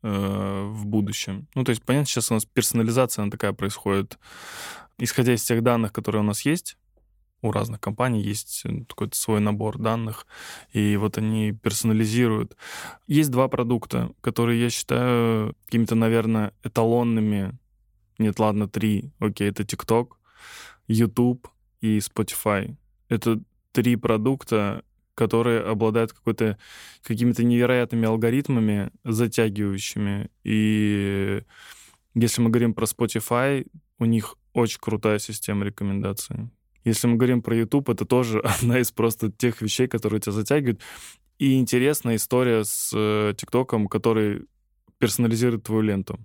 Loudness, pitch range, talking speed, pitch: -24 LUFS, 105-120 Hz, 125 wpm, 115 Hz